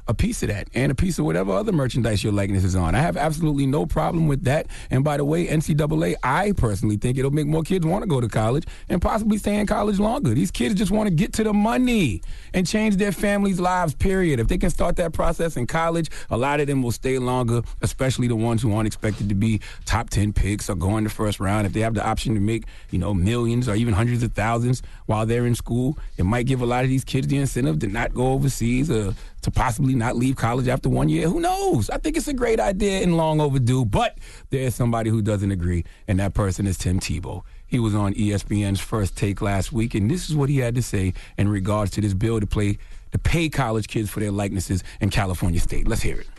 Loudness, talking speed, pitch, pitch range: -22 LUFS, 250 wpm, 120 Hz, 105-150 Hz